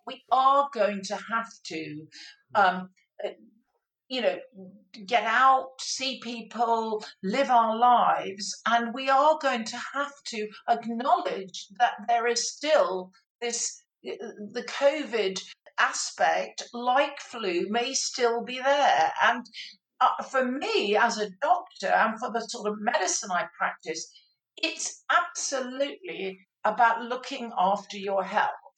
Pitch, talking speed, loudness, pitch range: 235 Hz, 125 wpm, -26 LUFS, 205-265 Hz